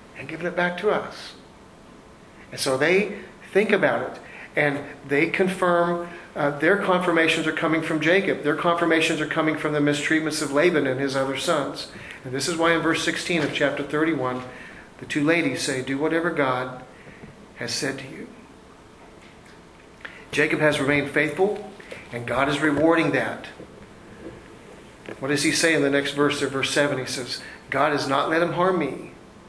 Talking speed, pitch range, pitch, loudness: 175 wpm, 140-170 Hz, 155 Hz, -22 LUFS